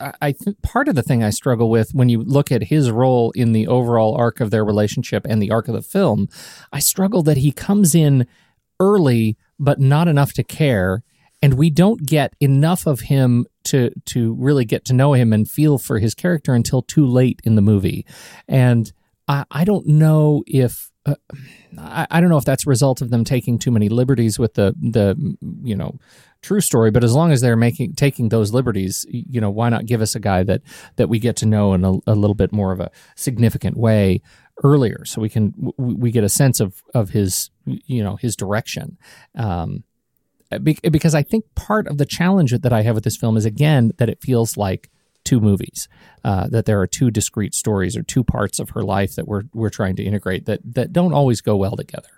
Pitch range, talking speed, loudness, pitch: 110-145 Hz, 215 wpm, -17 LUFS, 120 Hz